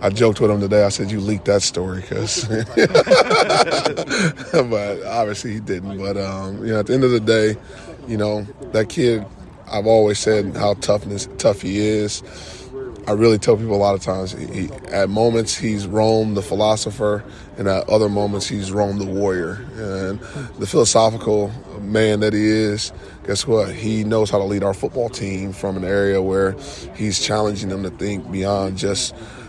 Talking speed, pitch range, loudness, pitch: 185 wpm, 95-110 Hz, -19 LUFS, 105 Hz